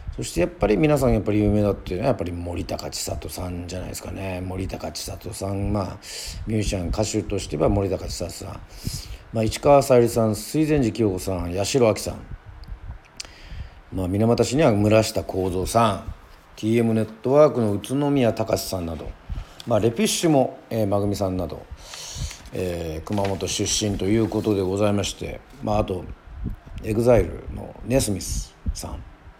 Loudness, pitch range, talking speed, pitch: -23 LUFS, 90-110 Hz, 345 characters per minute, 100 Hz